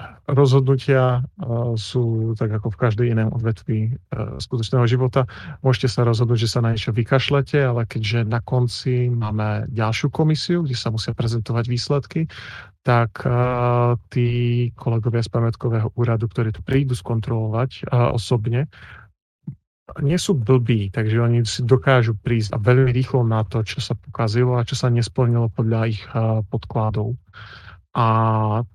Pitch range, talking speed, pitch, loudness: 115-125 Hz, 140 wpm, 120 Hz, -20 LUFS